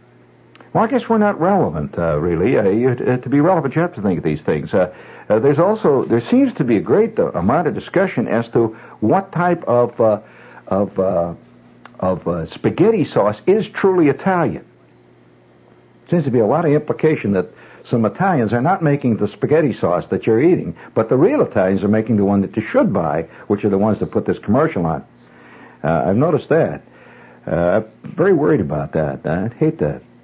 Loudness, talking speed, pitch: -17 LUFS, 200 wpm, 105 Hz